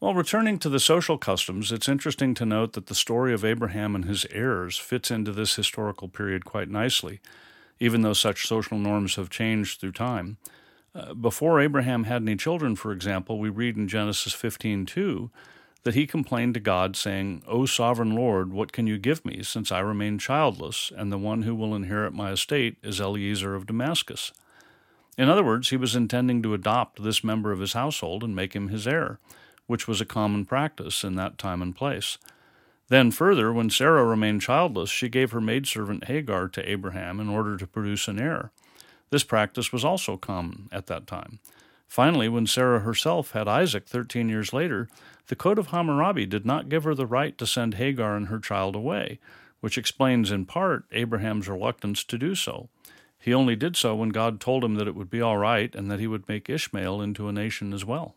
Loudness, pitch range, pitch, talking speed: -26 LUFS, 105-125 Hz, 110 Hz, 200 wpm